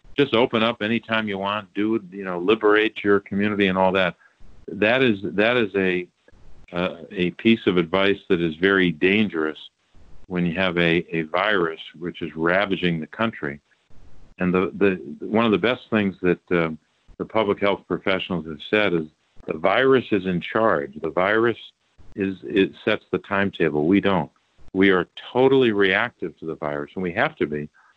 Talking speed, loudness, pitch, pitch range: 180 wpm, -22 LUFS, 95 Hz, 85-105 Hz